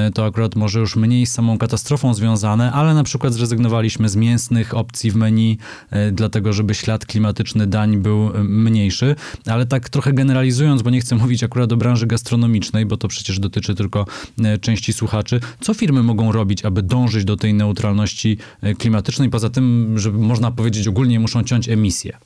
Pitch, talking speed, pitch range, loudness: 110 Hz, 170 wpm, 105-120 Hz, -17 LUFS